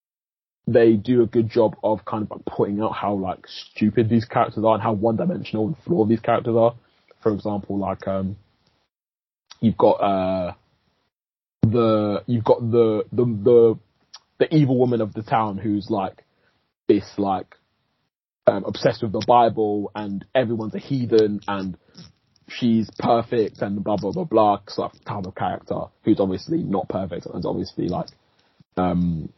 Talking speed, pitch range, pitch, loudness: 160 wpm, 100-120 Hz, 110 Hz, -22 LUFS